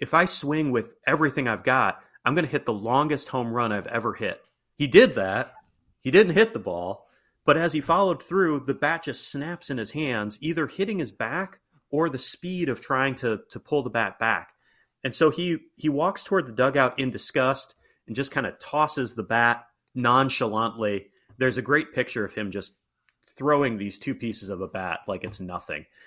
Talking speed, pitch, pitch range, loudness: 200 wpm, 130 Hz, 115-150 Hz, -25 LUFS